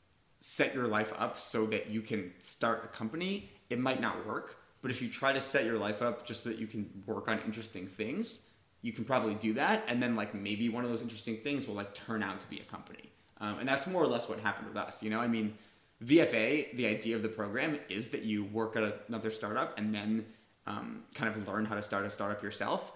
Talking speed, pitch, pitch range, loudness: 245 wpm, 110 Hz, 105-120 Hz, -35 LUFS